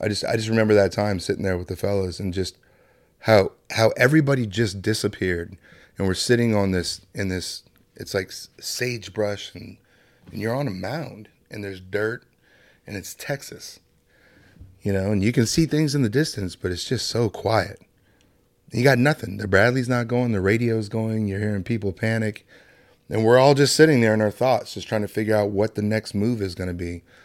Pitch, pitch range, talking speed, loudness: 105 Hz, 95-120 Hz, 205 wpm, -22 LUFS